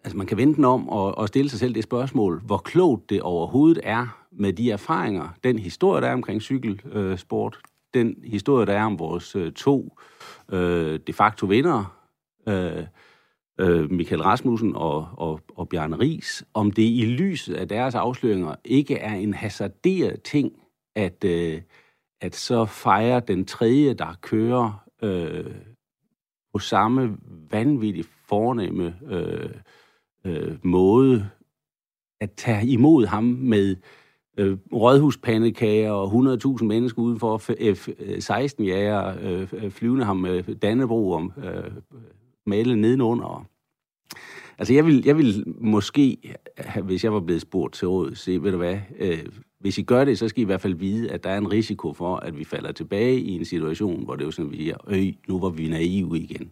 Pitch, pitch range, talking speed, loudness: 105 Hz, 95-120 Hz, 170 wpm, -23 LUFS